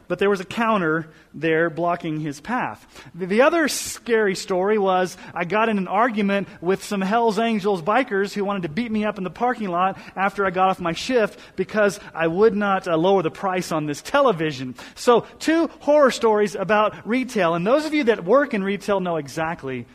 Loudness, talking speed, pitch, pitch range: -21 LUFS, 200 wpm, 195 Hz, 175-220 Hz